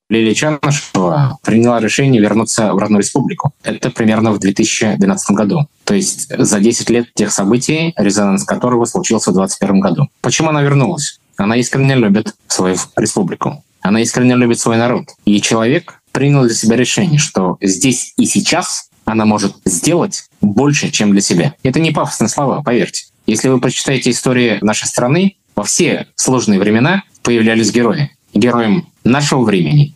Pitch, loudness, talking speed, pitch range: 120 Hz, -13 LUFS, 150 wpm, 110-145 Hz